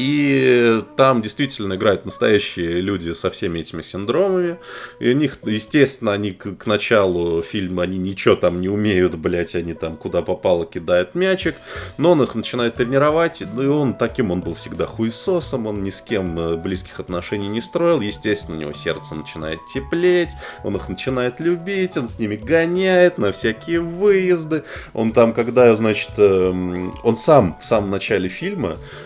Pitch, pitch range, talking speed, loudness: 110 Hz, 95-145 Hz, 160 wpm, -19 LUFS